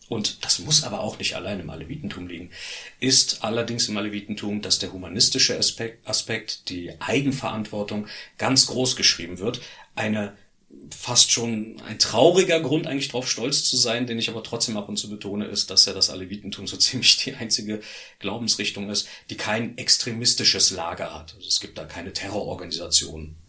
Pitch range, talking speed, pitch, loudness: 100-120 Hz, 170 wpm, 105 Hz, -21 LUFS